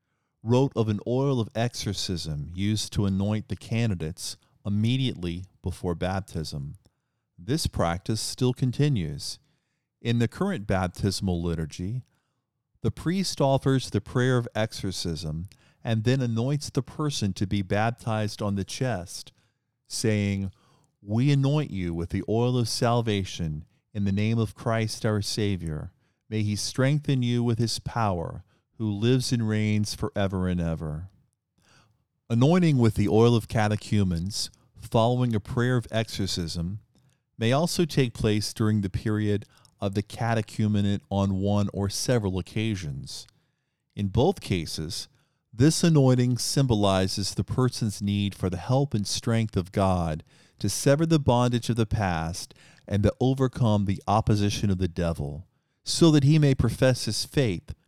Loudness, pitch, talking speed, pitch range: -26 LUFS, 110 Hz, 140 wpm, 100-125 Hz